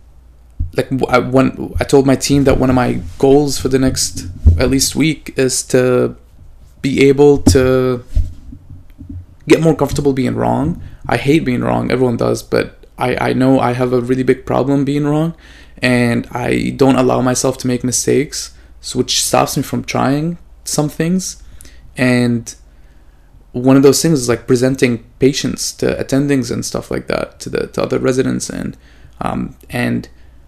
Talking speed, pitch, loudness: 165 wpm, 125 Hz, -15 LUFS